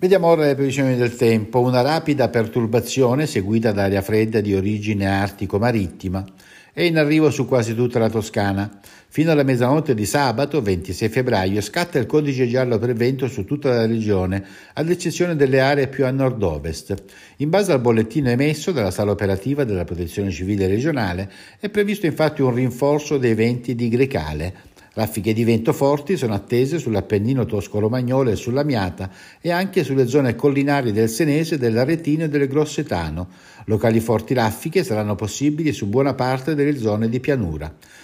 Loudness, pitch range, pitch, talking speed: -20 LUFS, 105-145 Hz, 120 Hz, 160 wpm